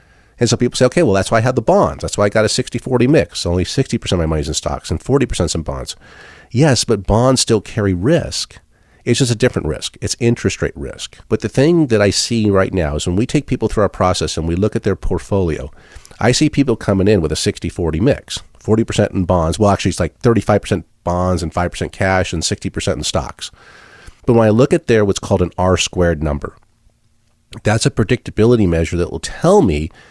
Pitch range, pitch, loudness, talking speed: 90-120 Hz, 100 Hz, -16 LUFS, 230 wpm